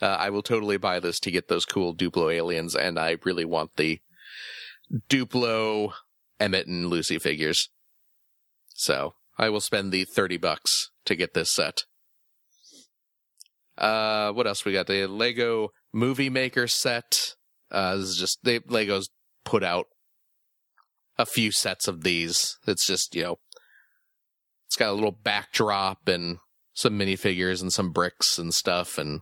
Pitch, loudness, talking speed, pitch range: 100 Hz, -25 LUFS, 150 wpm, 90-110 Hz